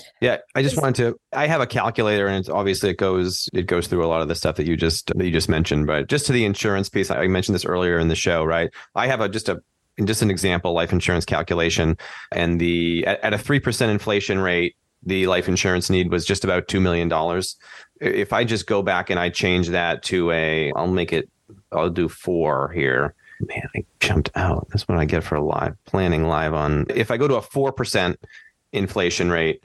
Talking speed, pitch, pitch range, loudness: 225 wpm, 90 Hz, 85-100 Hz, -21 LUFS